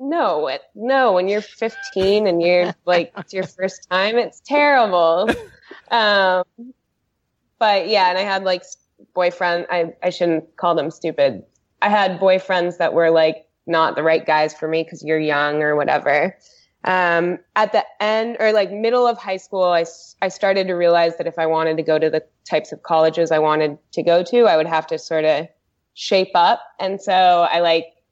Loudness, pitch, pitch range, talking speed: -18 LUFS, 180 Hz, 160-195 Hz, 190 wpm